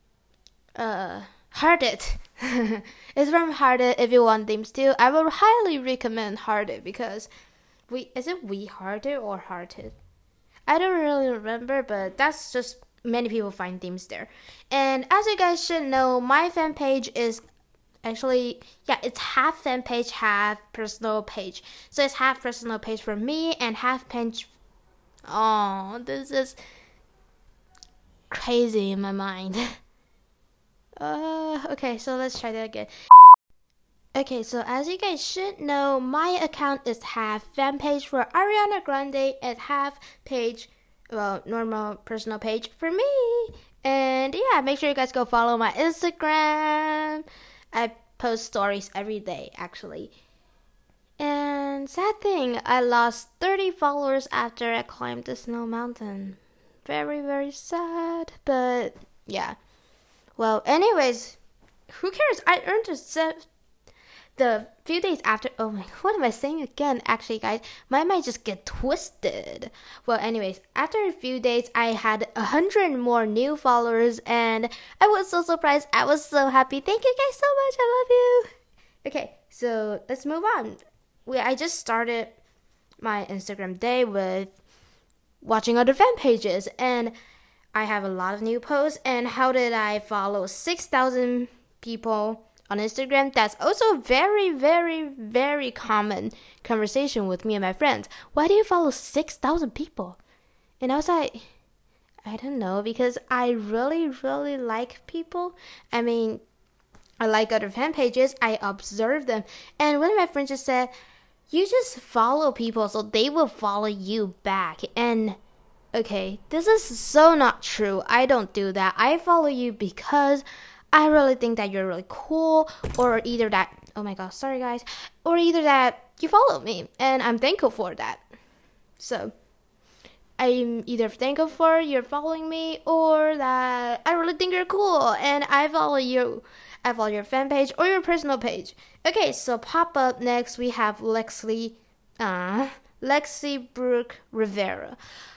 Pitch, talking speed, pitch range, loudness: 250 Hz, 150 wpm, 225-300 Hz, -23 LUFS